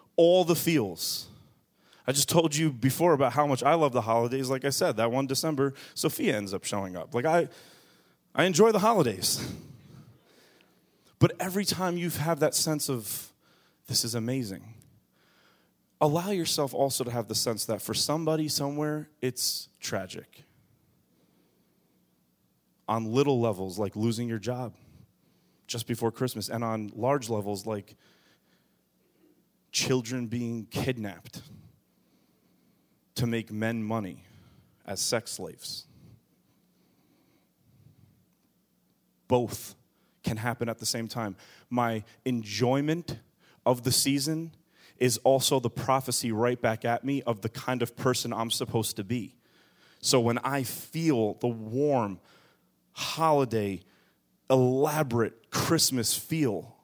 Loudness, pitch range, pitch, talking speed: -28 LUFS, 115-145 Hz, 125 Hz, 125 wpm